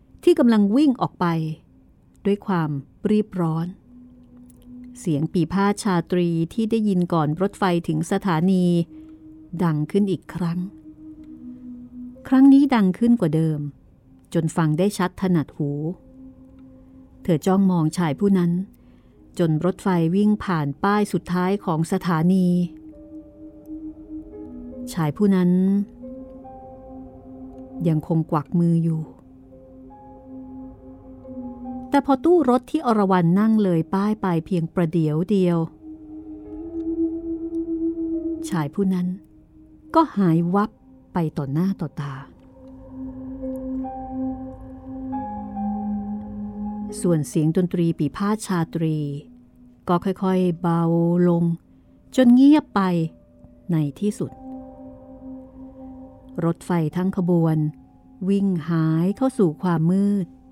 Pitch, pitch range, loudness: 180 Hz, 160-250 Hz, -22 LUFS